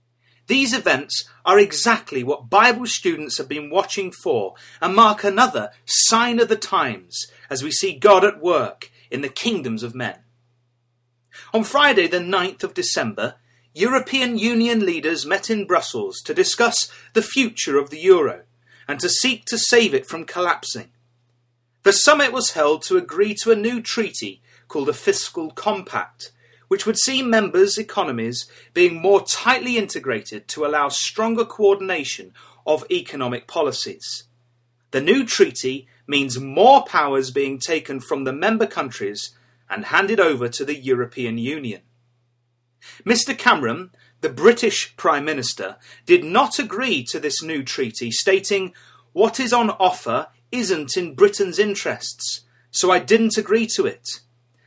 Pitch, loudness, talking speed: 195 Hz, -19 LUFS, 145 wpm